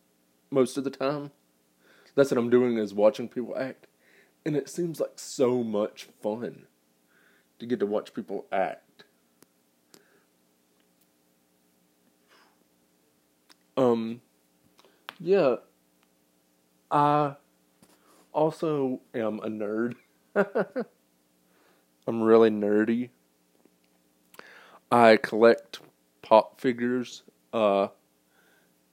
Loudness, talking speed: -26 LUFS, 85 wpm